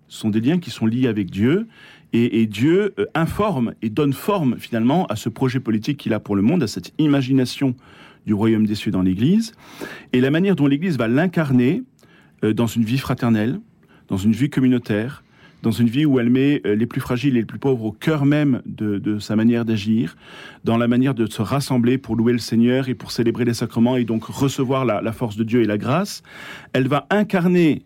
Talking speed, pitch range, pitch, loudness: 220 wpm, 110-140 Hz, 125 Hz, -20 LUFS